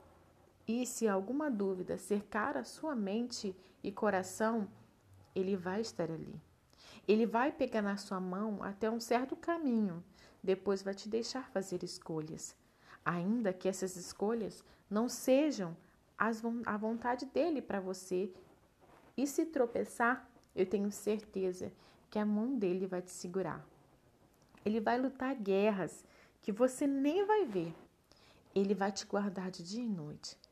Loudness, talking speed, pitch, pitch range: -37 LUFS, 140 wpm, 210 Hz, 190-235 Hz